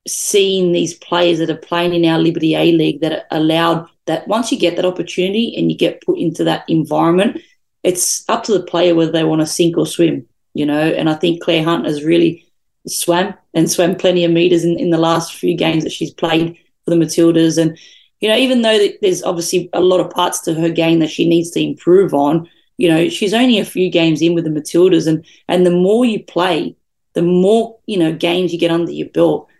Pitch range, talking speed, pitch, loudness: 165-180 Hz, 225 wpm, 170 Hz, -15 LUFS